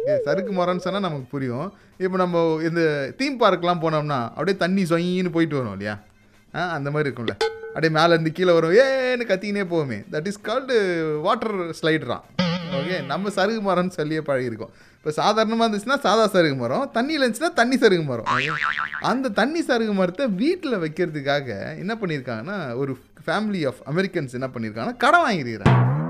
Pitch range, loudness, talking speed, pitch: 145-205 Hz, -22 LUFS, 145 wpm, 175 Hz